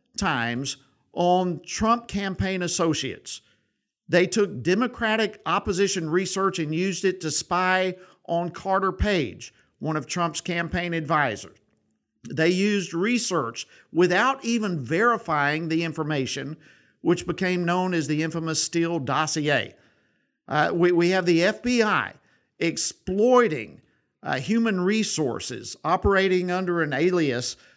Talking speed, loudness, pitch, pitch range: 115 wpm, -24 LUFS, 175 Hz, 160-190 Hz